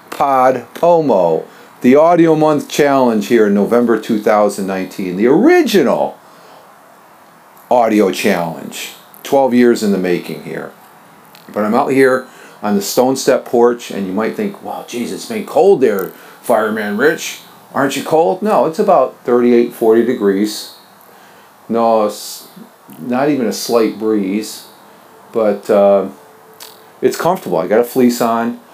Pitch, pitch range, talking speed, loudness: 120 Hz, 105-130 Hz, 140 wpm, -14 LUFS